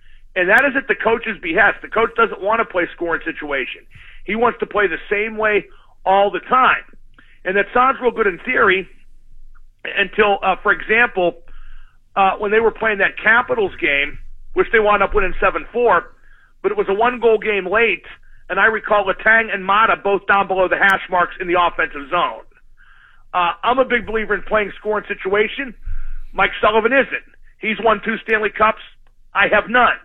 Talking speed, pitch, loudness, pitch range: 190 wpm, 210 Hz, -17 LUFS, 190-225 Hz